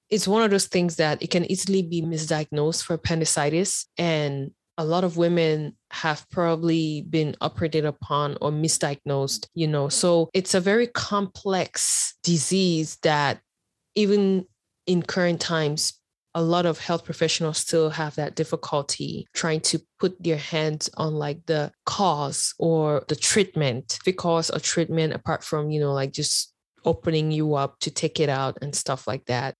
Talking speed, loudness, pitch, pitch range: 160 wpm, -24 LUFS, 160 Hz, 150-170 Hz